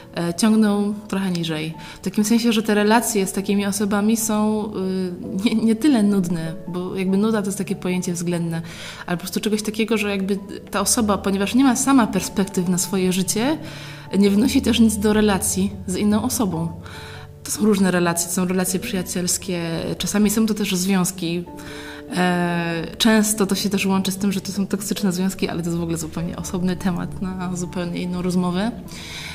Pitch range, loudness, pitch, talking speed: 180-215 Hz, -21 LUFS, 195 Hz, 180 wpm